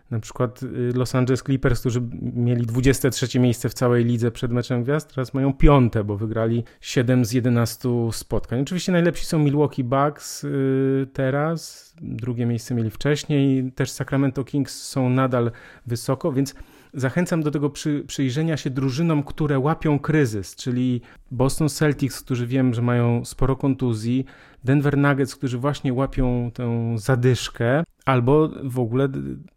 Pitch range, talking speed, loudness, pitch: 120-145 Hz, 140 wpm, -22 LUFS, 130 Hz